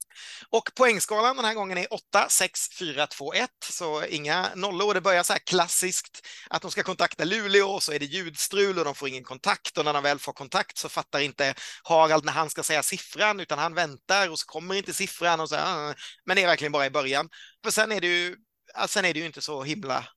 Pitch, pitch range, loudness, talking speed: 175 Hz, 150-195 Hz, -25 LUFS, 235 wpm